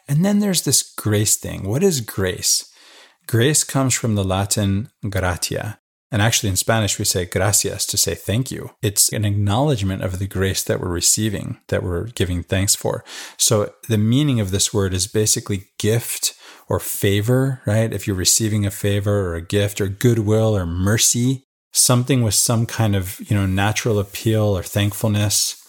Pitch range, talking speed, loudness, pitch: 100-115 Hz, 175 wpm, -19 LUFS, 105 Hz